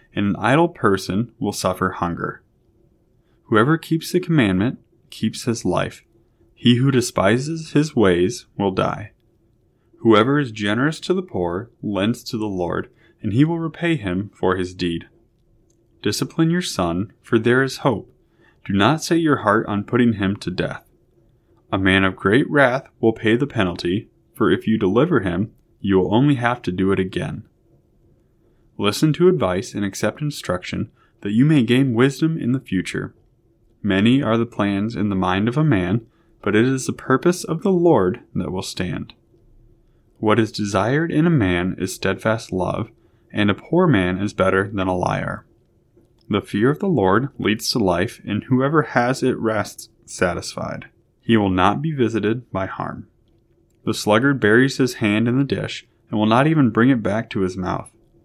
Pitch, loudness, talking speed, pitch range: 115 Hz, -20 LUFS, 175 wpm, 100-135 Hz